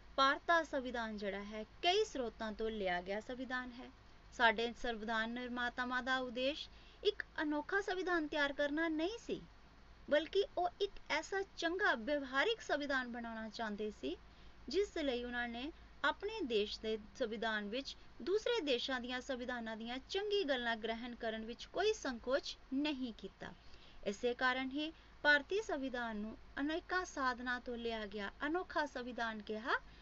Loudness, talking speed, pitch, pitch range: -39 LUFS, 140 wpm, 260 Hz, 230-325 Hz